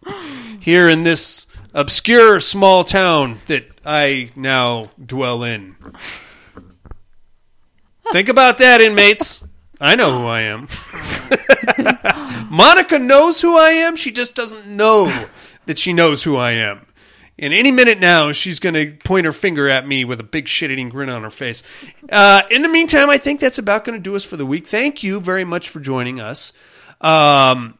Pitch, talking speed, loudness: 165 Hz, 170 wpm, -12 LUFS